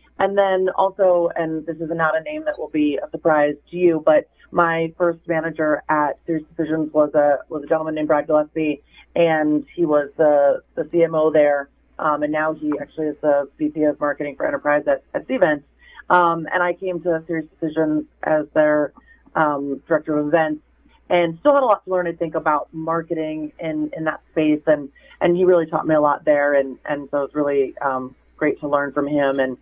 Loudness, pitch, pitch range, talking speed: -20 LUFS, 155 Hz, 150-170 Hz, 205 wpm